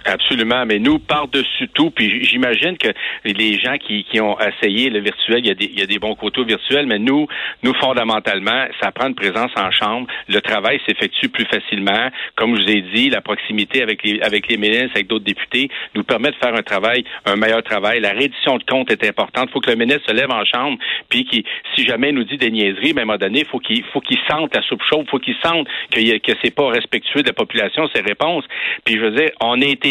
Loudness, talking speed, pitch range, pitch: -16 LUFS, 255 wpm, 105-145 Hz, 115 Hz